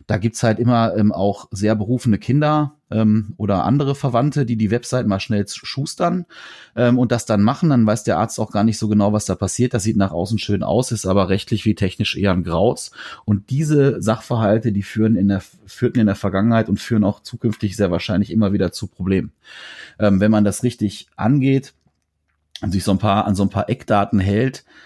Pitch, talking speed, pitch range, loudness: 110 Hz, 215 wpm, 100-120 Hz, -19 LUFS